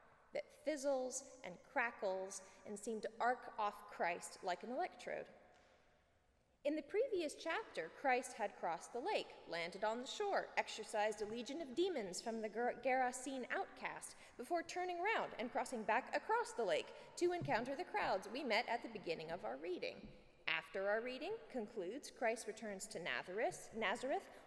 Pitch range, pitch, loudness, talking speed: 215-345 Hz, 250 Hz, -43 LUFS, 155 wpm